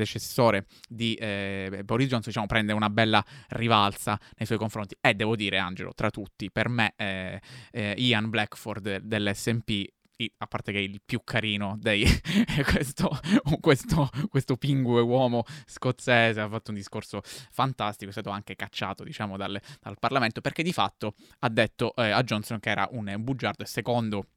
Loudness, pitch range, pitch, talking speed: -27 LUFS, 105-125 Hz, 110 Hz, 170 wpm